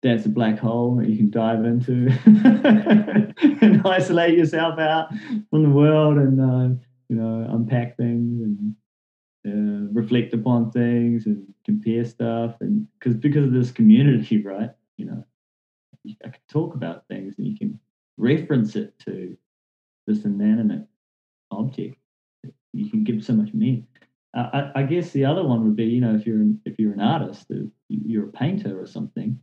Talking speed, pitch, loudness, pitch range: 170 wpm, 125 Hz, -20 LUFS, 115-170 Hz